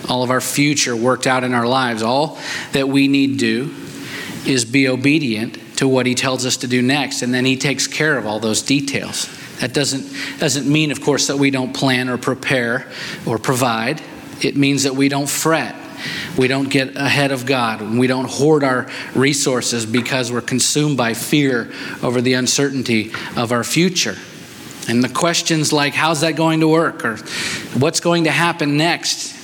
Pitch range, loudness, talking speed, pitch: 125-145 Hz, -17 LUFS, 190 wpm, 135 Hz